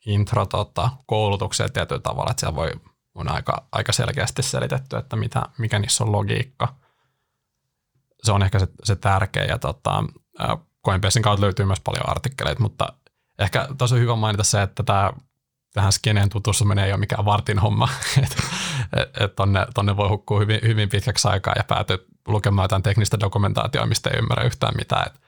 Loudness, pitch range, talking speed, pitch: -22 LUFS, 100-125 Hz, 165 wpm, 110 Hz